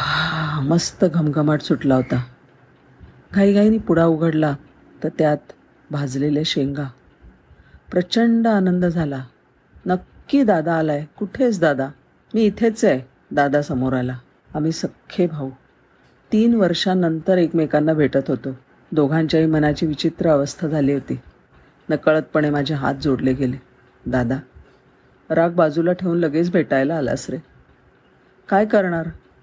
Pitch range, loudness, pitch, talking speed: 140-175 Hz, -19 LUFS, 155 Hz, 110 wpm